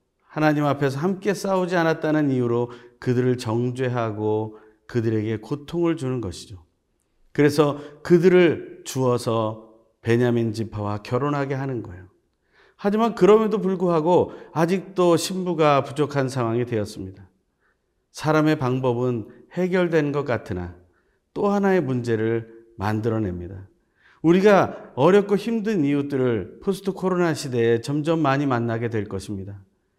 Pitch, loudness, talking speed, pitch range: 130 Hz, -22 LUFS, 295 characters per minute, 110-165 Hz